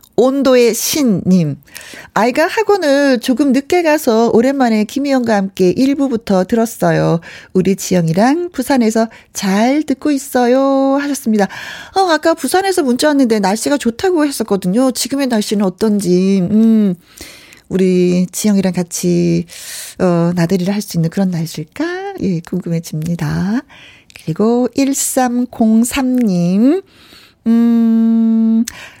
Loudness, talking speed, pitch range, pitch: -14 LUFS, 255 characters per minute, 190-270 Hz, 225 Hz